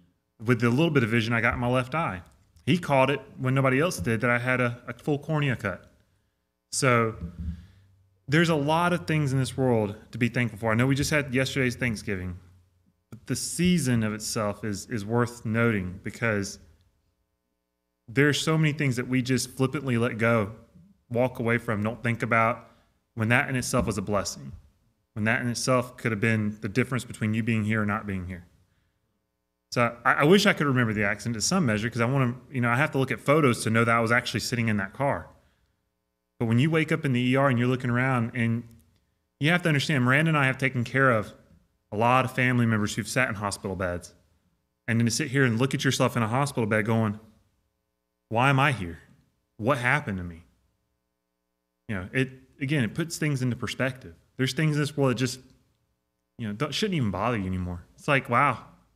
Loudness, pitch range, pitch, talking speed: -26 LUFS, 100-130 Hz, 115 Hz, 220 wpm